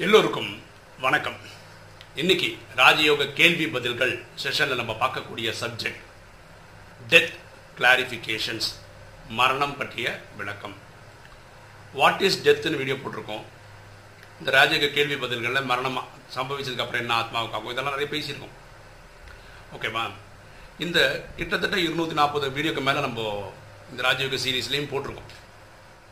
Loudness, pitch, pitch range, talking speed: -23 LUFS, 120 Hz, 105-140 Hz, 100 wpm